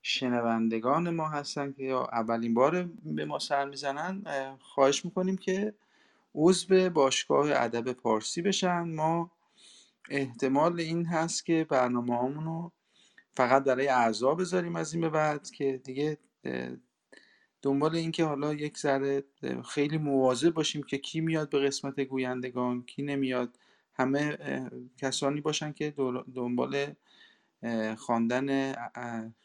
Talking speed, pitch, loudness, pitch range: 120 wpm, 140 Hz, -30 LUFS, 125-160 Hz